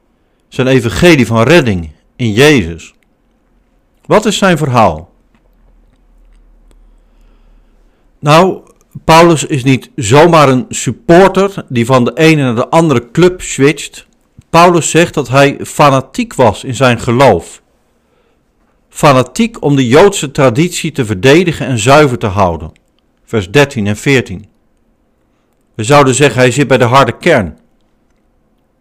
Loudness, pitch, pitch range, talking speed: -9 LUFS, 135 Hz, 120-160 Hz, 125 wpm